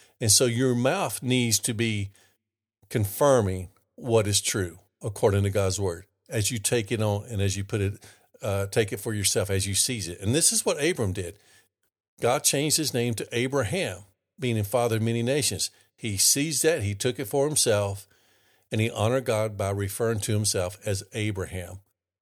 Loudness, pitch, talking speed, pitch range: -25 LUFS, 110 Hz, 190 wpm, 100-120 Hz